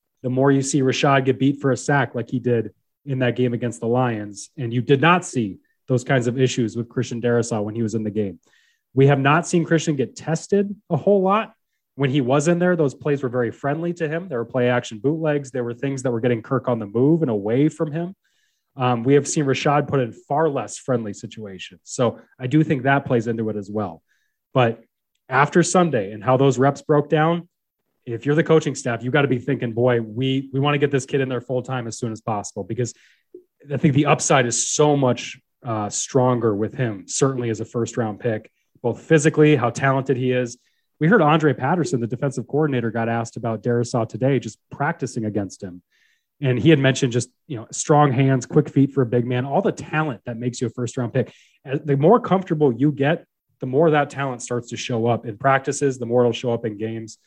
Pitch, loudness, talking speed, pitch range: 130 Hz, -21 LUFS, 235 wpm, 120-150 Hz